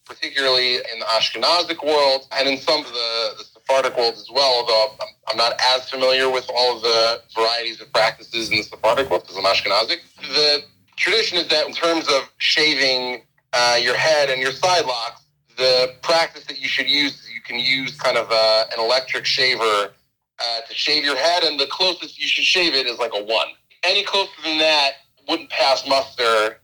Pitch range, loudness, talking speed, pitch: 120-150 Hz, -18 LUFS, 200 wpm, 135 Hz